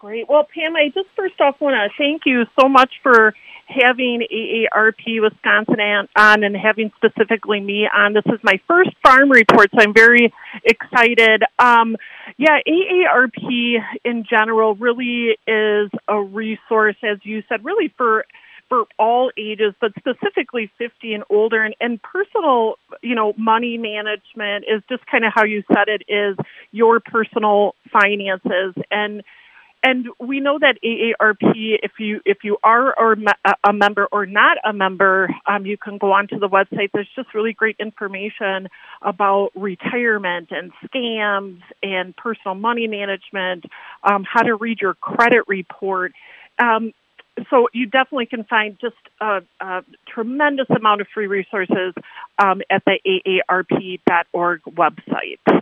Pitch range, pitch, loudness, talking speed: 205-240 Hz, 220 Hz, -16 LUFS, 145 wpm